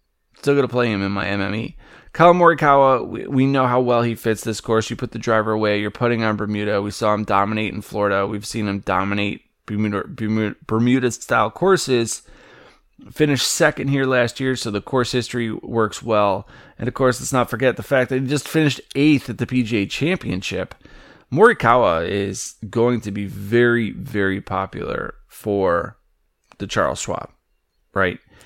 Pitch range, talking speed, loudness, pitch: 105-130 Hz, 175 wpm, -20 LUFS, 115 Hz